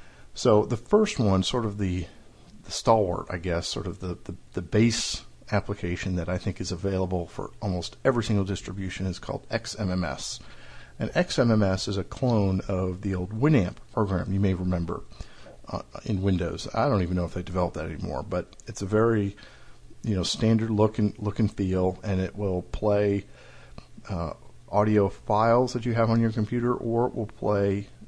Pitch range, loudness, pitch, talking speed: 95-110 Hz, -27 LUFS, 100 Hz, 180 wpm